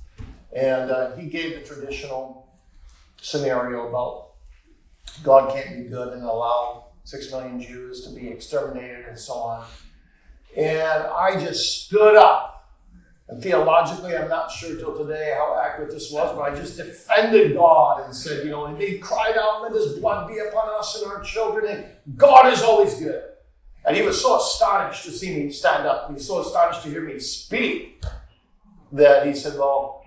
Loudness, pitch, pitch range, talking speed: -20 LUFS, 150 Hz, 125-200 Hz, 175 wpm